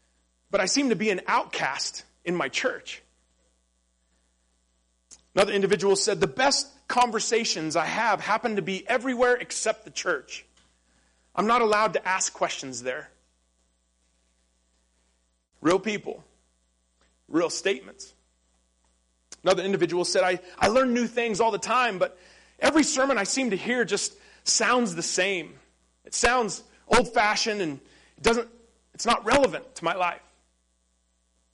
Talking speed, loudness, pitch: 135 wpm, -25 LUFS, 180 Hz